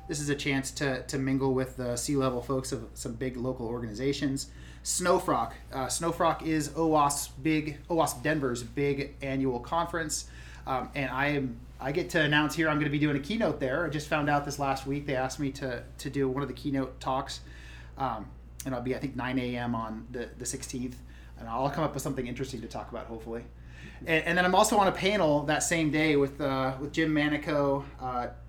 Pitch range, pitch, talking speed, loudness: 125-150 Hz, 135 Hz, 215 wpm, -30 LUFS